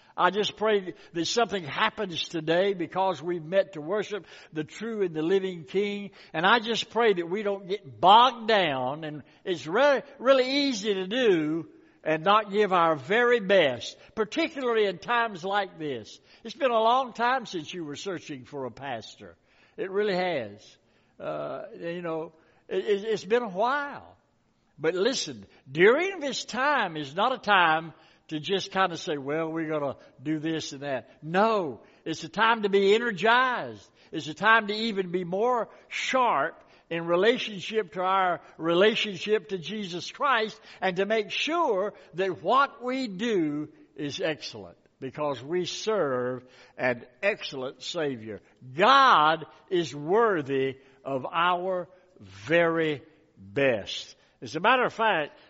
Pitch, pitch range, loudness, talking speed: 190 Hz, 160-220 Hz, -26 LUFS, 155 wpm